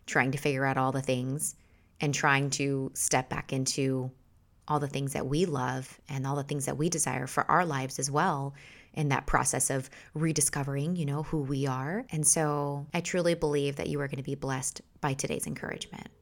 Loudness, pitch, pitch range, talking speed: -30 LUFS, 140 Hz, 130-150 Hz, 205 wpm